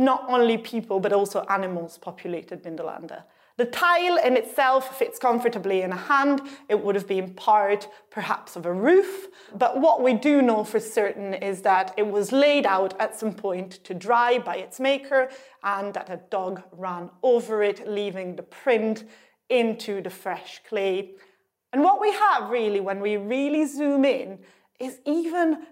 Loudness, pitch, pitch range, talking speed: -24 LUFS, 220 Hz, 195-265 Hz, 170 wpm